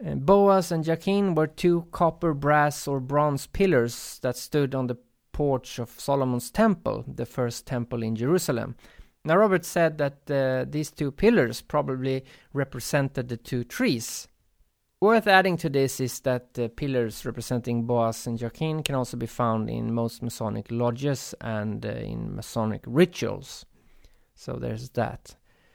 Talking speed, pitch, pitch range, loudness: 150 wpm, 130 Hz, 120-155 Hz, -26 LUFS